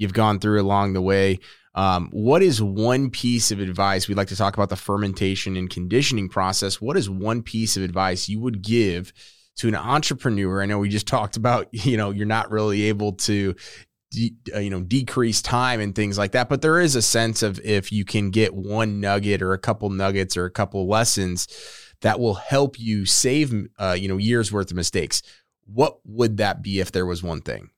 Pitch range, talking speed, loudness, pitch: 95-115 Hz, 215 wpm, -22 LUFS, 105 Hz